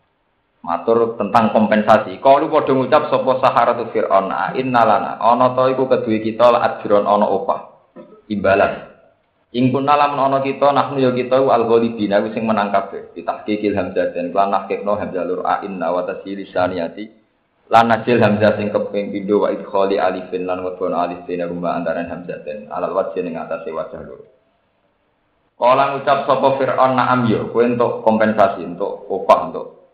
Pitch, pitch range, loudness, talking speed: 110 Hz, 100-130 Hz, -17 LUFS, 160 wpm